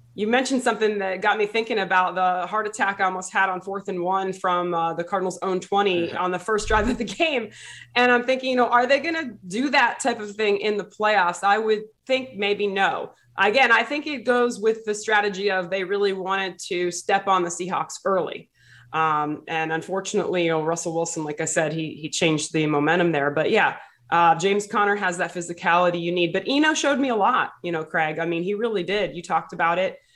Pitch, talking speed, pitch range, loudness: 195 Hz, 230 wpm, 175-215 Hz, -22 LUFS